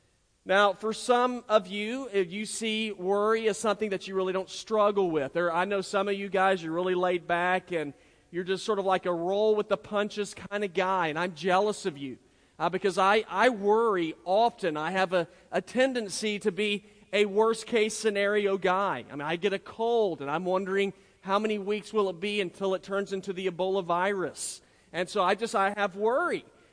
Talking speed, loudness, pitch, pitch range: 200 wpm, -28 LUFS, 195 Hz, 185-210 Hz